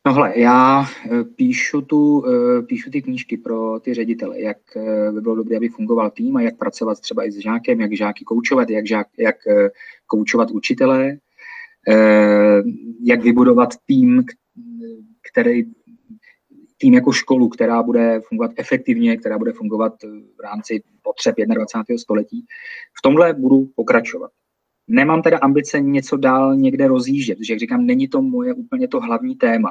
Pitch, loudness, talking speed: 225 Hz, -17 LUFS, 145 wpm